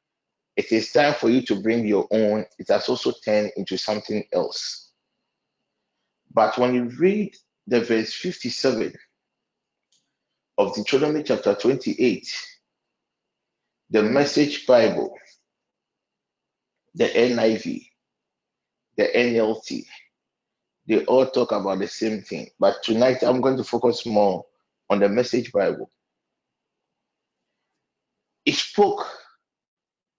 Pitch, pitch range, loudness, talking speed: 120 Hz, 110-145 Hz, -22 LUFS, 110 wpm